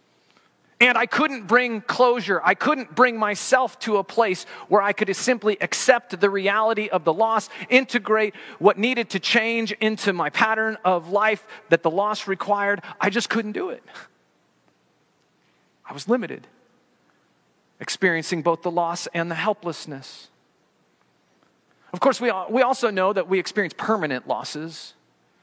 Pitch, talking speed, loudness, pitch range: 205 Hz, 145 wpm, -22 LUFS, 175-230 Hz